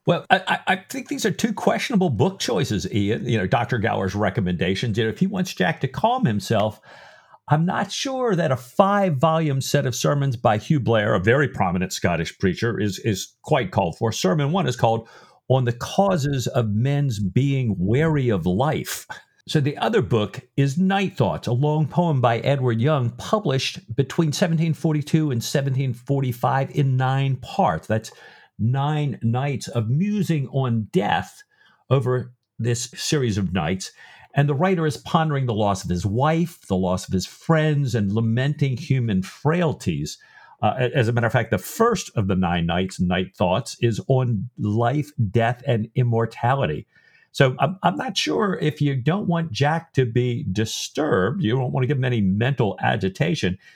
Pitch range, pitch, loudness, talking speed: 115-155 Hz, 130 Hz, -22 LUFS, 170 wpm